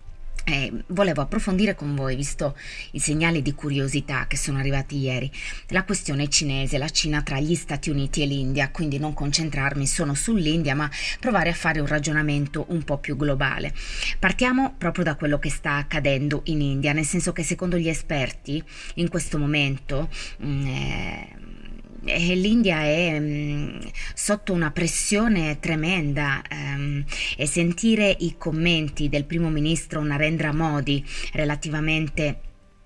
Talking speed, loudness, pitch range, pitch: 140 wpm, -24 LUFS, 140-170 Hz, 150 Hz